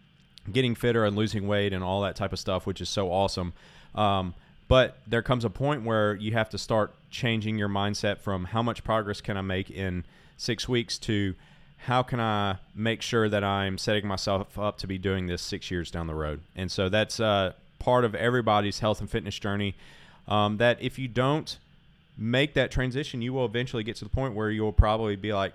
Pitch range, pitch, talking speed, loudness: 100-120 Hz, 105 Hz, 215 wpm, -28 LUFS